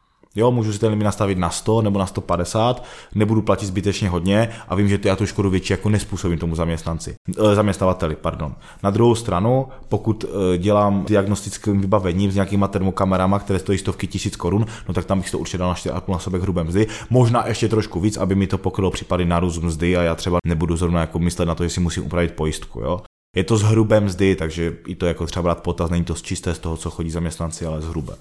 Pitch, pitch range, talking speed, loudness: 95 Hz, 85-105 Hz, 230 wpm, -20 LUFS